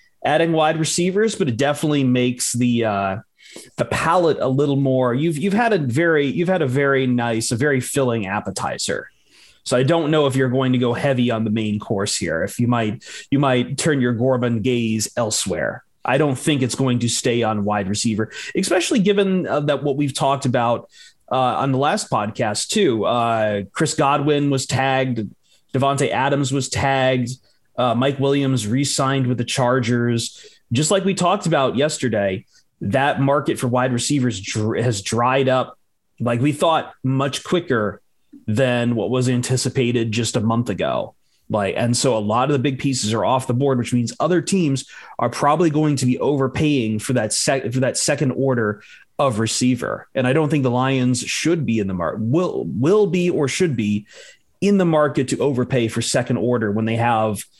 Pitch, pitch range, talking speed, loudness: 130 Hz, 120-145 Hz, 190 wpm, -19 LUFS